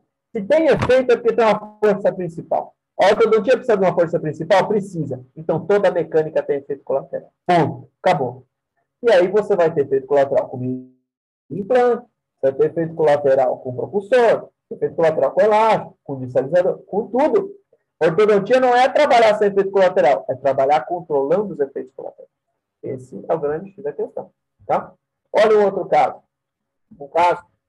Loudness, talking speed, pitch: -18 LUFS, 170 wpm, 200 Hz